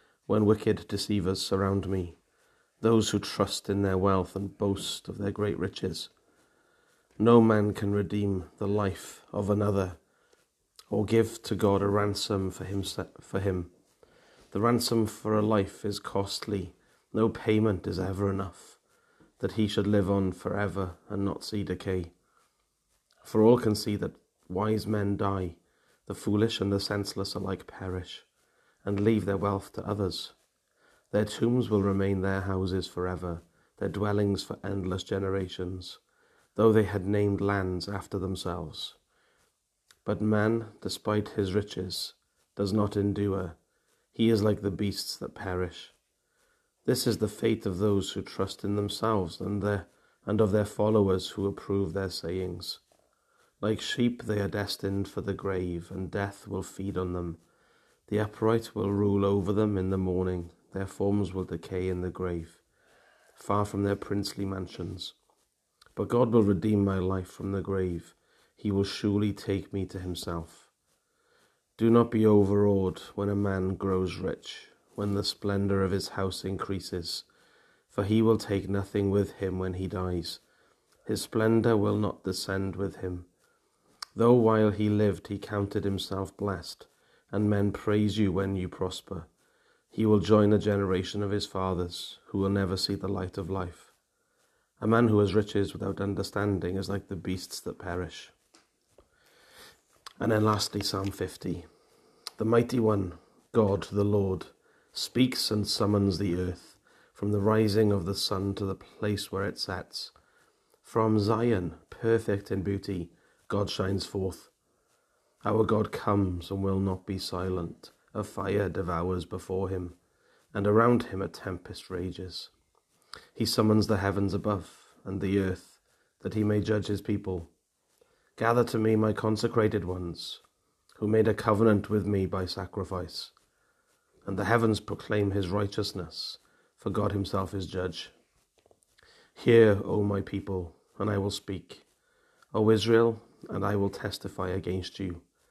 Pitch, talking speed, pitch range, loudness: 100 Hz, 155 wpm, 95-105 Hz, -29 LUFS